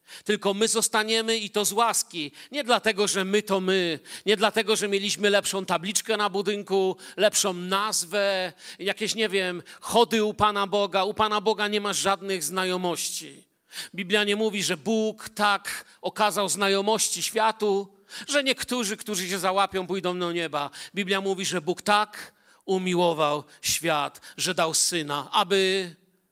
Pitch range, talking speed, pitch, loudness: 185-215 Hz, 150 wpm, 200 Hz, -25 LUFS